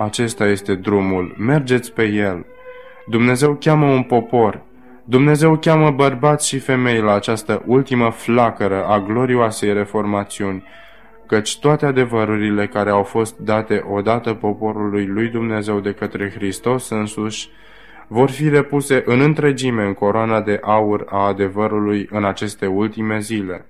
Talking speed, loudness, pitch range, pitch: 130 wpm, -17 LUFS, 105-130 Hz, 110 Hz